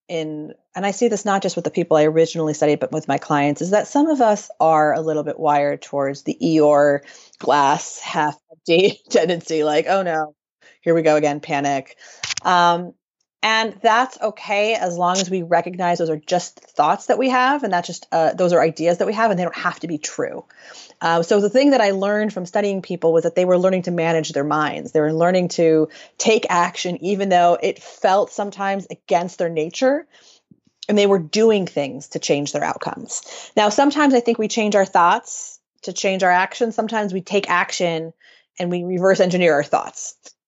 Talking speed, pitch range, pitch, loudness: 205 wpm, 155-205 Hz, 175 Hz, -19 LUFS